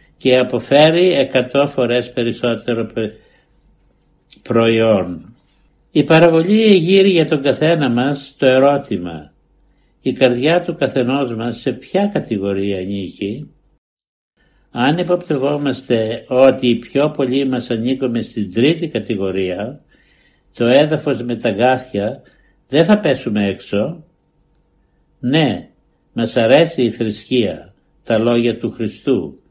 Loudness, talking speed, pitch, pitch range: -16 LUFS, 110 wpm, 125 Hz, 115-145 Hz